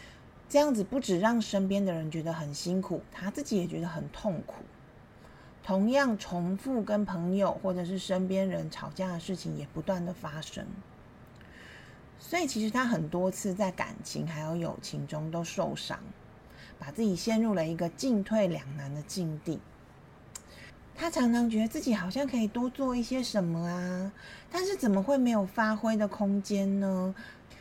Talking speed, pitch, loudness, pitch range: 245 characters per minute, 195 Hz, -31 LUFS, 175-225 Hz